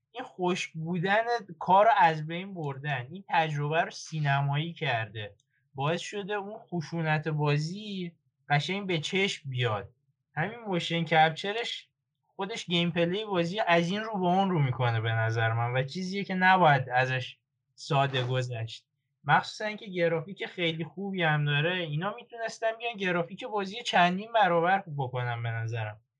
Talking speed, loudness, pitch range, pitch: 140 wpm, -29 LUFS, 135-190 Hz, 165 Hz